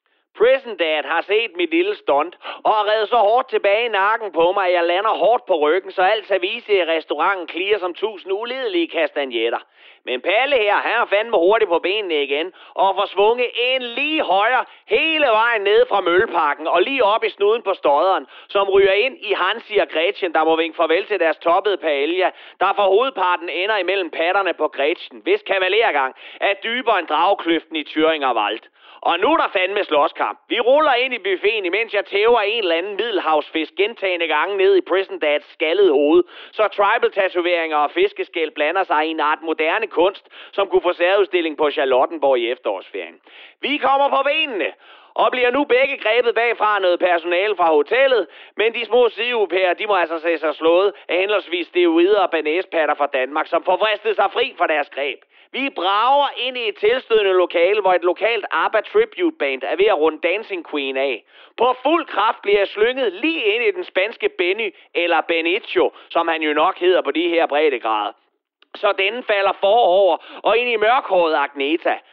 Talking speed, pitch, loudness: 190 wpm, 215 Hz, -18 LUFS